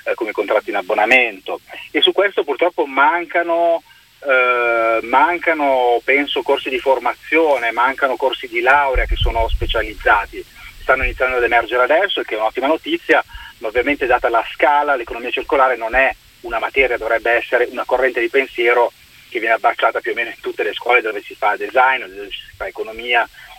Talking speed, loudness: 170 wpm, -16 LUFS